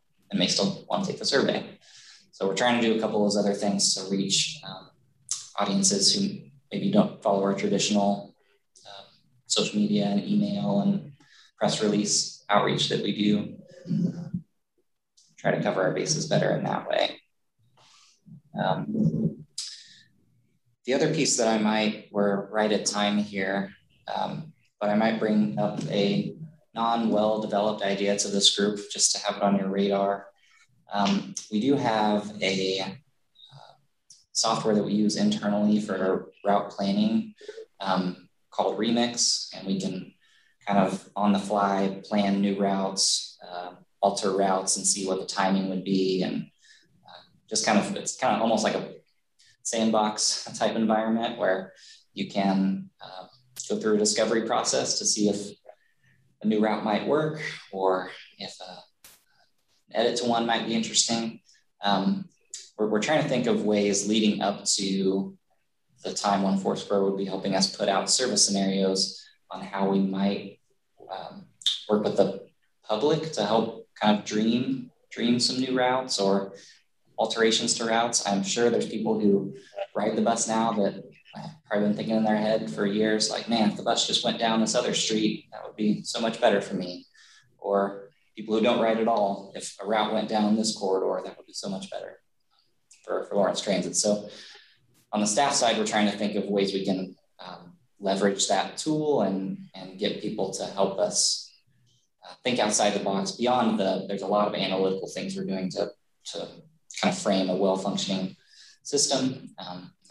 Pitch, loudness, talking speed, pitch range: 105 Hz, -26 LUFS, 175 wpm, 100-115 Hz